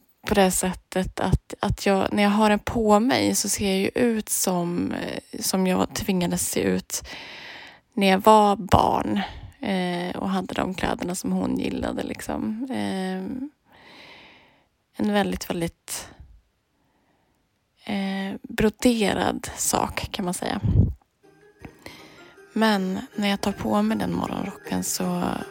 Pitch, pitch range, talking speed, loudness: 200 Hz, 185-220 Hz, 130 wpm, -24 LUFS